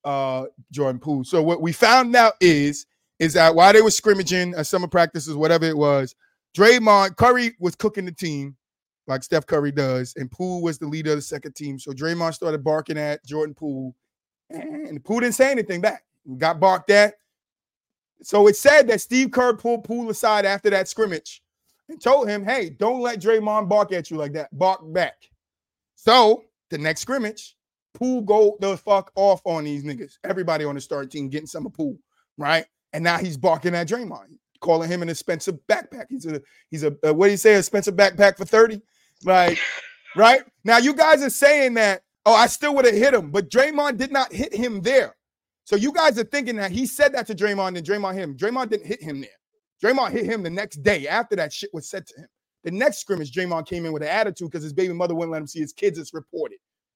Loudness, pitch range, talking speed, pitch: -20 LUFS, 160-230 Hz, 220 wpm, 195 Hz